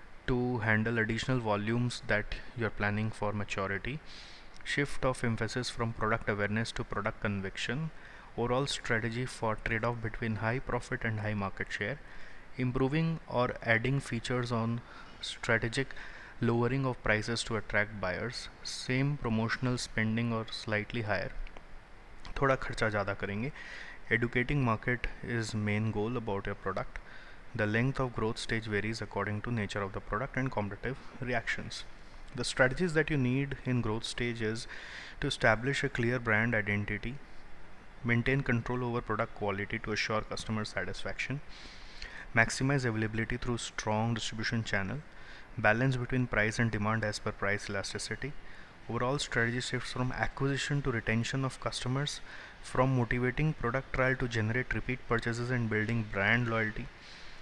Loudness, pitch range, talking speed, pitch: -33 LUFS, 105-125 Hz, 140 wpm, 115 Hz